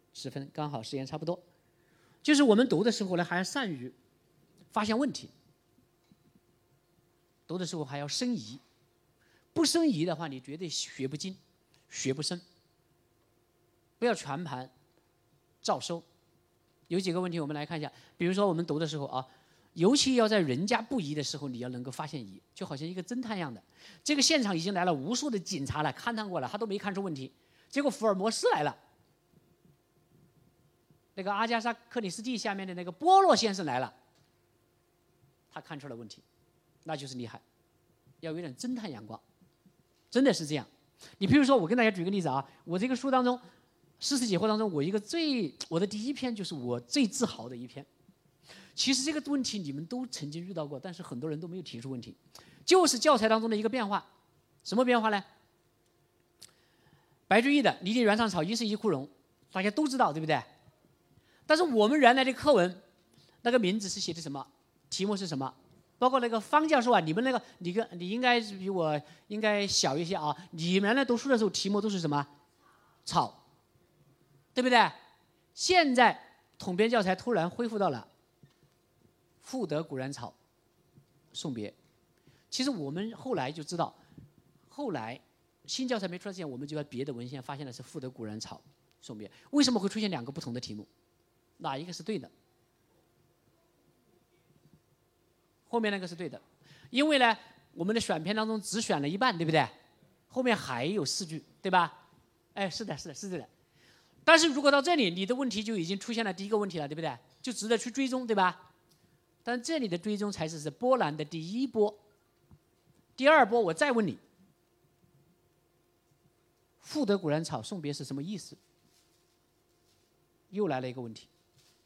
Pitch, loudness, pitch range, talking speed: 185 Hz, -30 LUFS, 150-230 Hz, 270 characters per minute